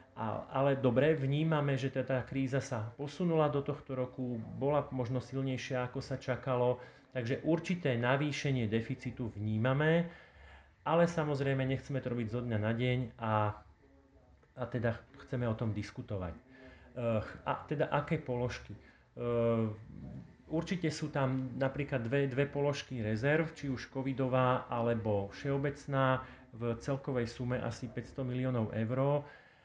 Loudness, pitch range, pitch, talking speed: -35 LUFS, 115-140 Hz, 130 Hz, 125 wpm